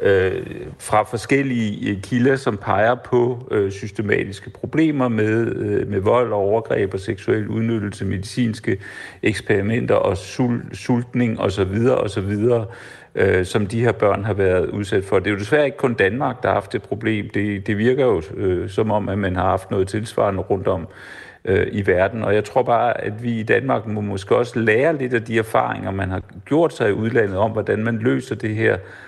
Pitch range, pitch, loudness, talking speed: 100-120 Hz, 110 Hz, -20 LUFS, 180 wpm